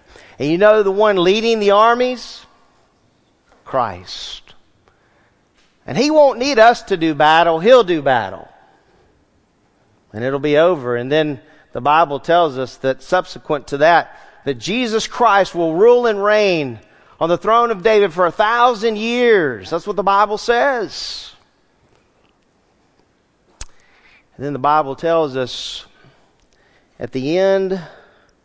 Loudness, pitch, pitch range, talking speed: -15 LUFS, 180 Hz, 145-220 Hz, 135 wpm